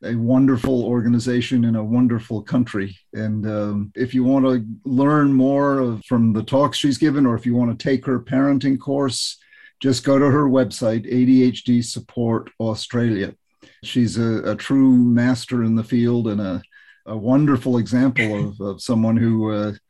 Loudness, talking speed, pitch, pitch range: -19 LUFS, 170 wpm, 120 Hz, 110-130 Hz